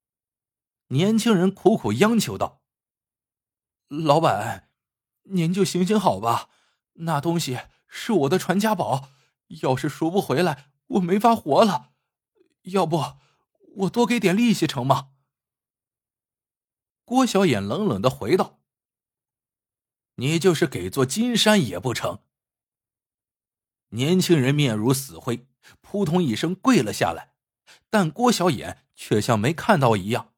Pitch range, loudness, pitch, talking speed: 125-195 Hz, -22 LUFS, 165 Hz, 180 characters per minute